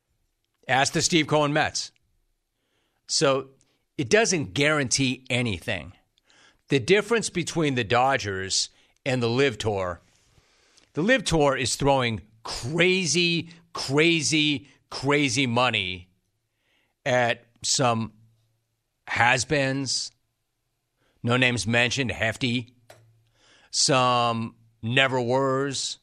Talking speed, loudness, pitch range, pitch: 85 wpm, -23 LUFS, 115-145 Hz, 125 Hz